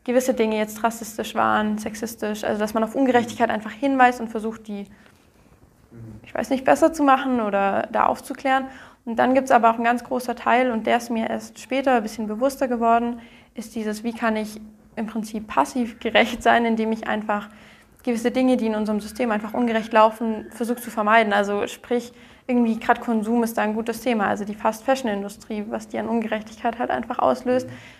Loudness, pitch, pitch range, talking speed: -22 LUFS, 230 Hz, 215-245 Hz, 195 wpm